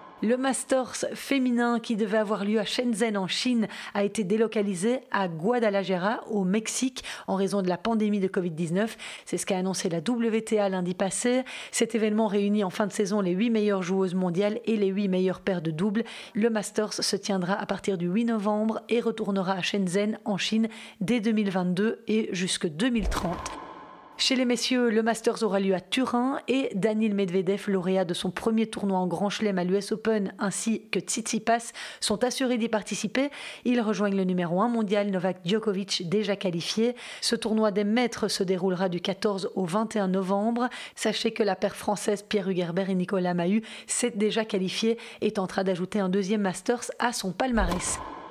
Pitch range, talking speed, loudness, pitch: 195-225 Hz, 180 wpm, -27 LUFS, 210 Hz